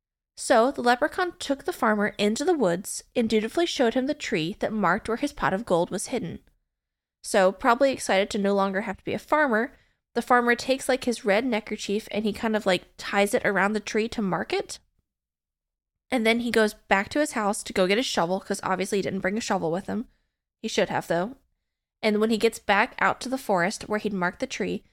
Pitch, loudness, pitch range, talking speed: 215 Hz, -25 LUFS, 195-250 Hz, 230 wpm